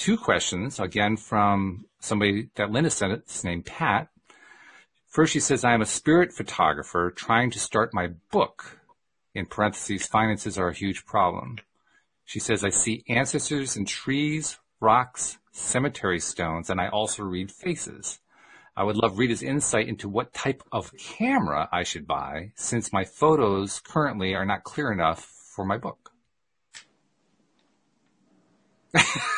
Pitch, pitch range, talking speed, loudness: 105 Hz, 95-125 Hz, 145 wpm, -25 LUFS